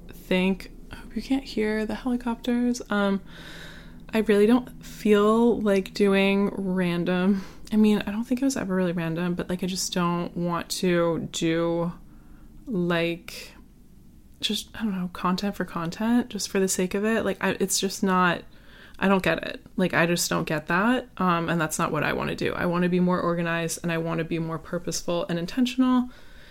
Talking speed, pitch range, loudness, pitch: 195 wpm, 175-215 Hz, -25 LUFS, 190 Hz